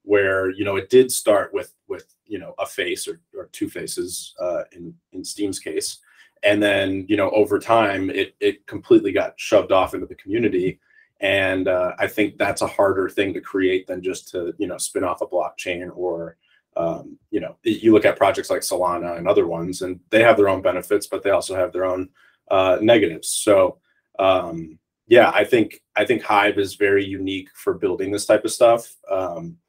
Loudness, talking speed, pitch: -20 LUFS, 200 wpm, 100 Hz